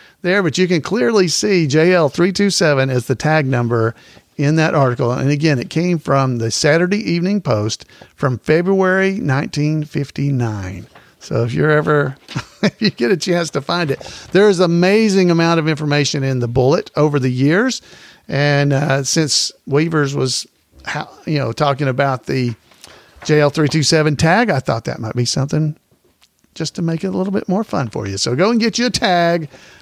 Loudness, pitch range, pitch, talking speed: -16 LUFS, 135-175 Hz, 150 Hz, 190 wpm